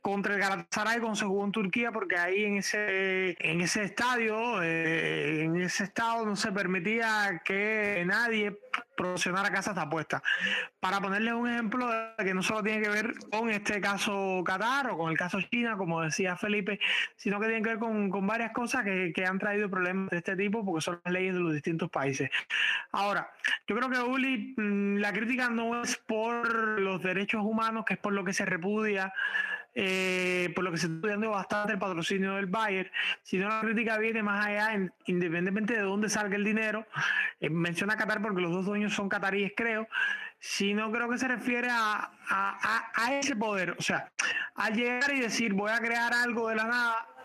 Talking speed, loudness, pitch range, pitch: 195 wpm, -30 LUFS, 190-225 Hz, 210 Hz